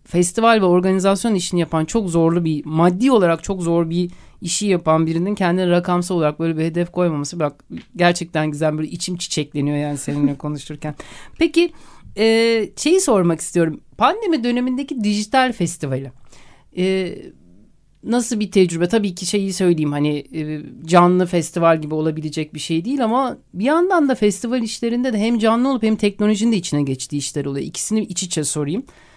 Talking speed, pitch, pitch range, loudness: 165 wpm, 175 Hz, 155-220 Hz, -19 LUFS